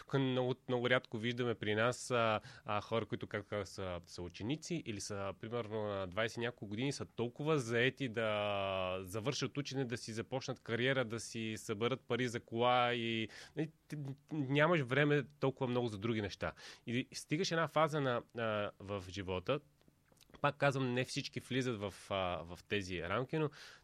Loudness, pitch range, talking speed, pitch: -38 LUFS, 105-135 Hz, 170 wpm, 120 Hz